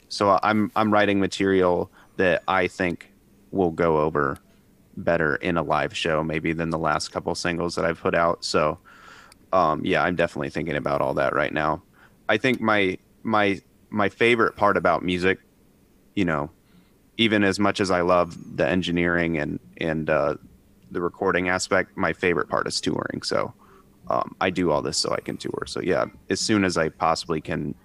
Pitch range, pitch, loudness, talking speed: 80-100 Hz, 90 Hz, -23 LUFS, 185 wpm